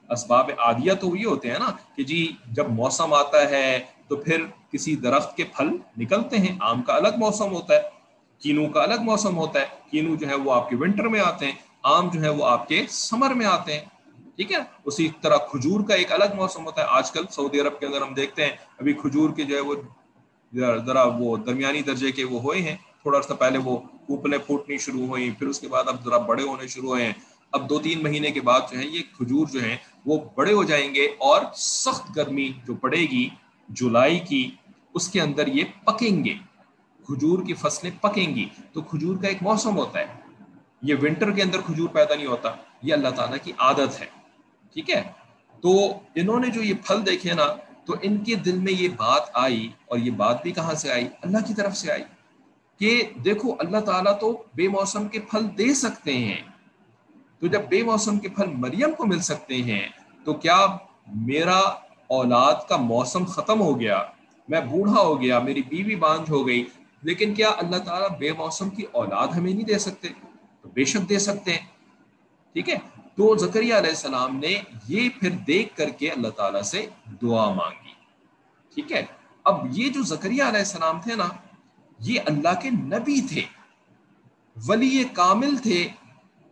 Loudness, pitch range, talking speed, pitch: -23 LUFS, 140-215 Hz, 200 wpm, 175 Hz